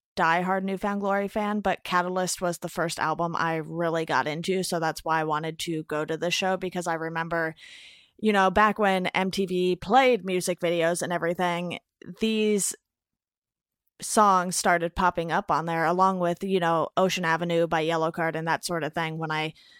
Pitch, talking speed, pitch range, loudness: 175 Hz, 190 wpm, 165-190 Hz, -26 LUFS